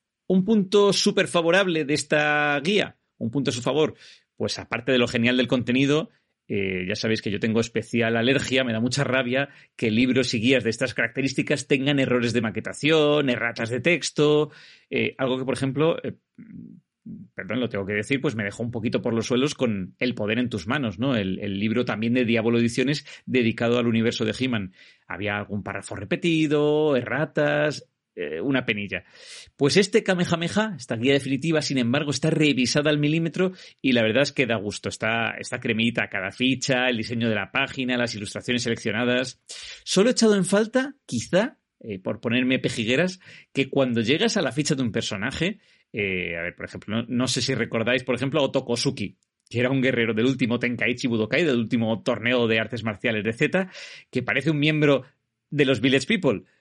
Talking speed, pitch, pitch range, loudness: 190 wpm, 125 Hz, 115-145 Hz, -23 LUFS